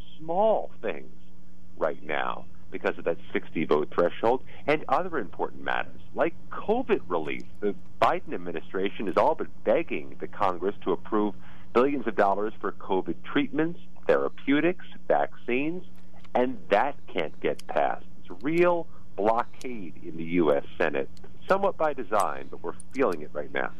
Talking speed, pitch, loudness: 145 wpm, 100 Hz, -28 LUFS